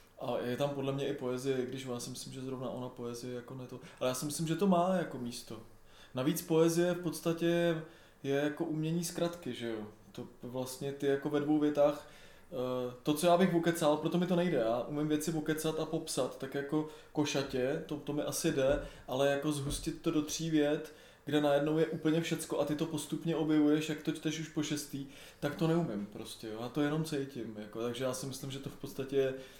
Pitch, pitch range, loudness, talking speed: 145 Hz, 130-160 Hz, -34 LUFS, 220 wpm